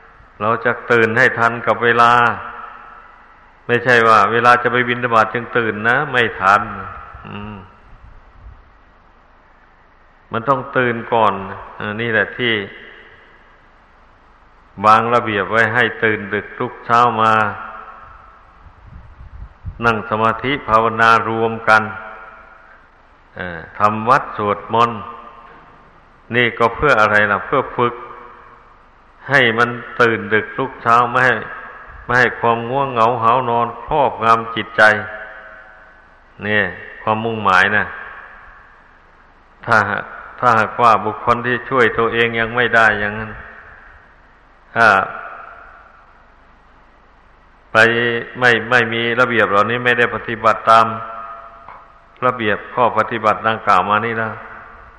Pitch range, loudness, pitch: 110-120 Hz, -15 LUFS, 115 Hz